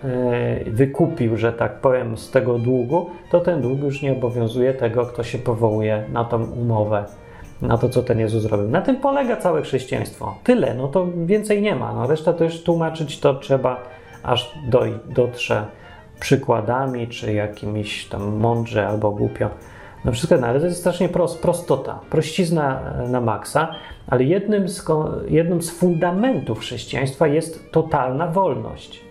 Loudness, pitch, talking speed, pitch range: -21 LUFS, 130 Hz, 155 wpm, 115-165 Hz